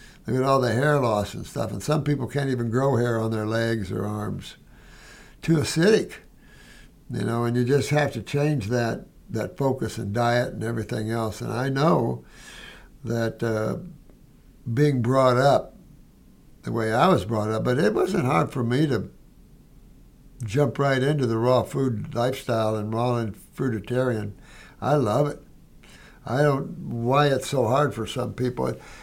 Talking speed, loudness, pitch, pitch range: 170 wpm, -24 LUFS, 125 Hz, 115-140 Hz